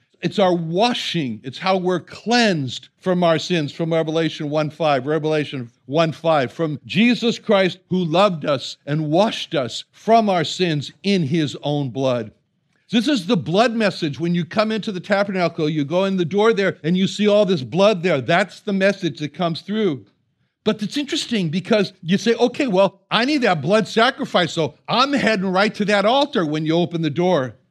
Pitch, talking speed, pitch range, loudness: 180 Hz, 190 wpm, 155-210 Hz, -19 LUFS